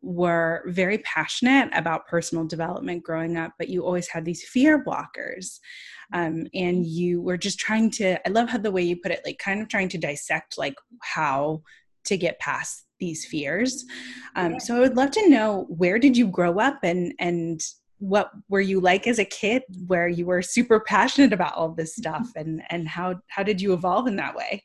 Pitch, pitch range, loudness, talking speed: 180 Hz, 170-220 Hz, -24 LUFS, 200 wpm